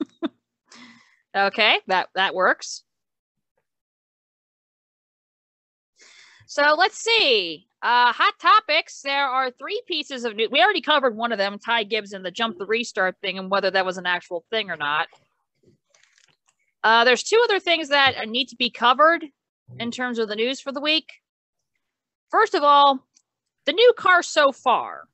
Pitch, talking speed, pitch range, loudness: 260 Hz, 155 wpm, 220-325 Hz, -20 LUFS